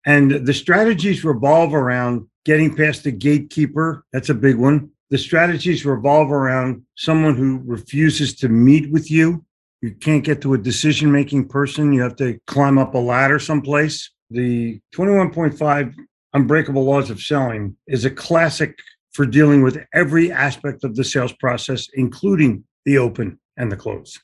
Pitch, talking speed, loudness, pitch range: 140 Hz, 160 wpm, -17 LUFS, 130-155 Hz